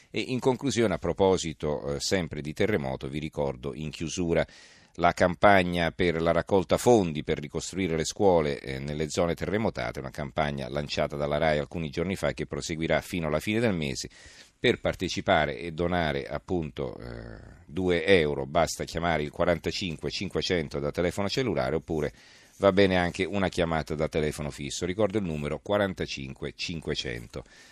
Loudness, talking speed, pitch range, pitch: -28 LUFS, 155 wpm, 75-90 Hz, 80 Hz